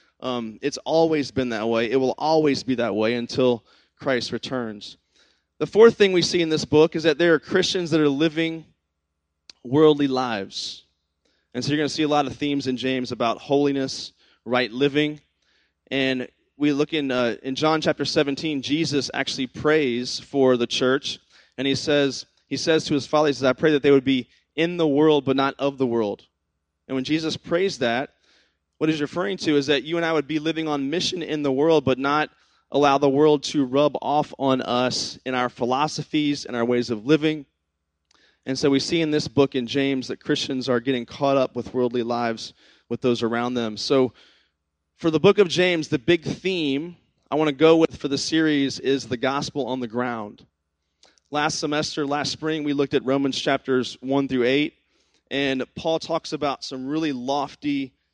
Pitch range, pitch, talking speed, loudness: 125-155 Hz, 140 Hz, 195 wpm, -22 LUFS